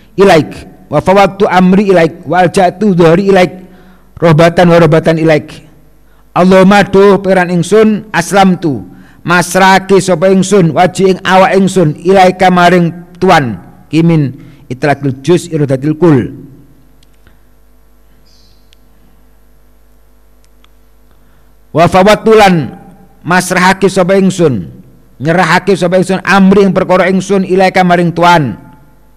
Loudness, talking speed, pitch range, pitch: -8 LUFS, 90 wpm, 150-190 Hz, 175 Hz